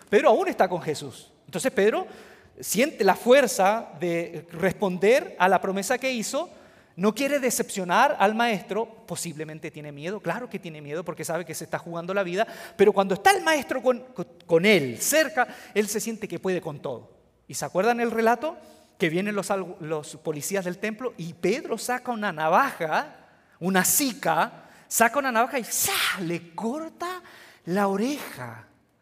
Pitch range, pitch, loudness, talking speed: 170-245 Hz, 200 Hz, -25 LUFS, 170 wpm